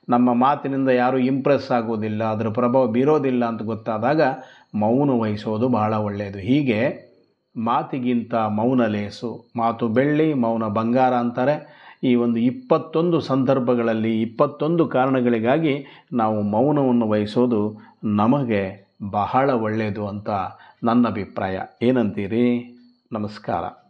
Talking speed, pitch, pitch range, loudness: 100 wpm, 120 Hz, 110-130 Hz, -21 LUFS